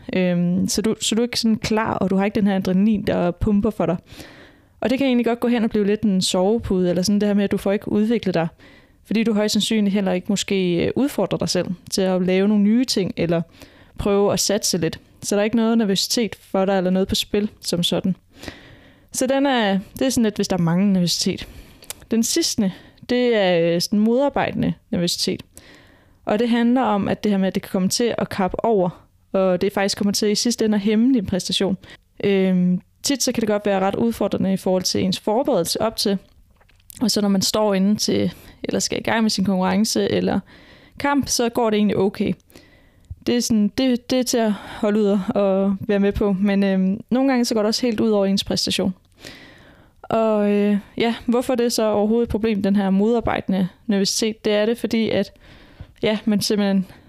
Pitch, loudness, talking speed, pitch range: 205 Hz, -20 LUFS, 220 wpm, 190-225 Hz